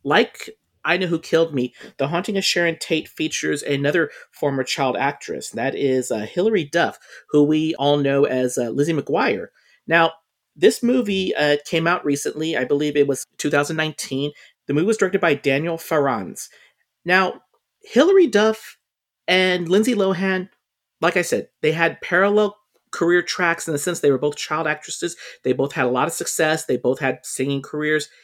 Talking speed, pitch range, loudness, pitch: 175 wpm, 145-185 Hz, -20 LUFS, 160 Hz